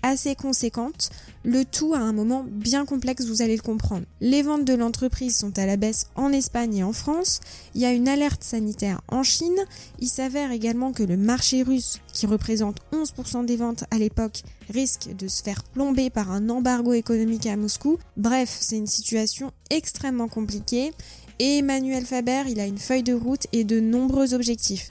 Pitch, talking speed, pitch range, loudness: 245 Hz, 190 wpm, 220-265 Hz, -23 LUFS